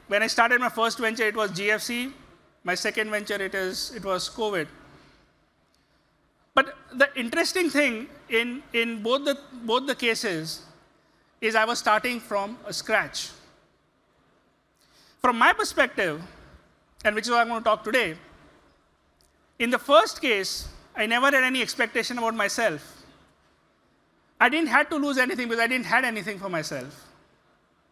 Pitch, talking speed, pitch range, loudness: 235 Hz, 155 wpm, 215-260 Hz, -24 LUFS